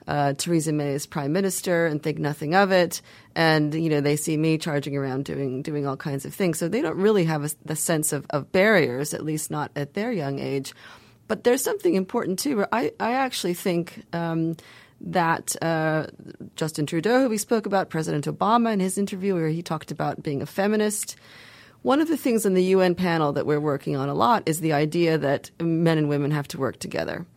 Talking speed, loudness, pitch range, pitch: 215 wpm, -24 LUFS, 145-190 Hz, 160 Hz